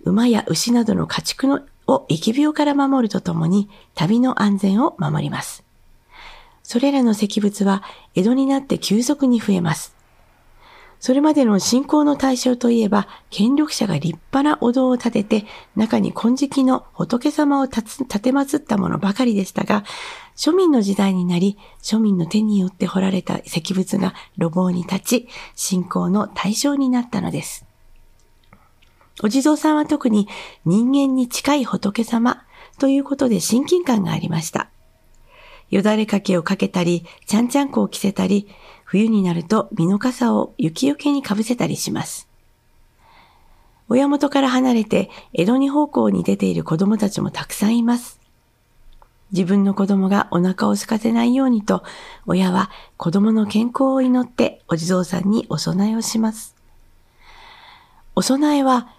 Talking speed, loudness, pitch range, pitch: 295 characters per minute, -19 LUFS, 195-270 Hz, 225 Hz